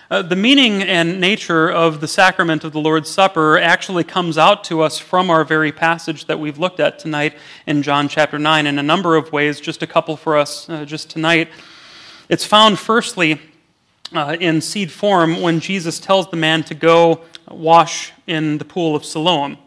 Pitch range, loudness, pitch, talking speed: 155-180 Hz, -15 LUFS, 165 Hz, 190 wpm